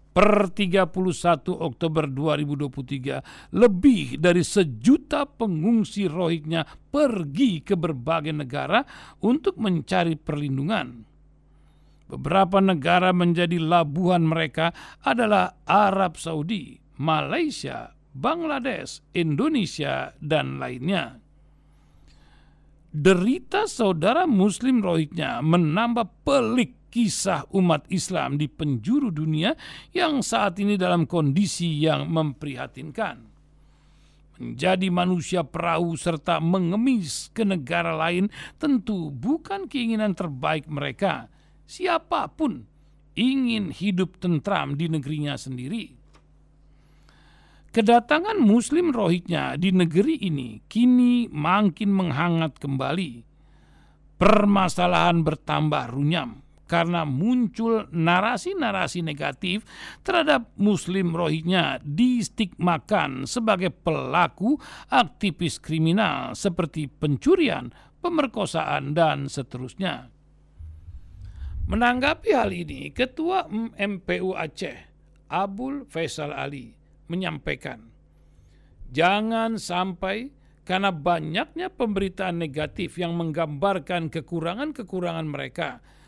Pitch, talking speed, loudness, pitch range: 175 Hz, 80 wpm, -24 LUFS, 155-215 Hz